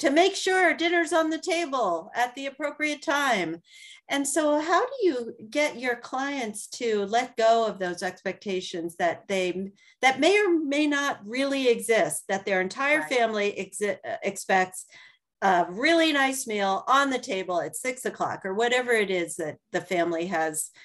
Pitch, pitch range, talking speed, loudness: 245 Hz, 195-300 Hz, 165 wpm, -25 LUFS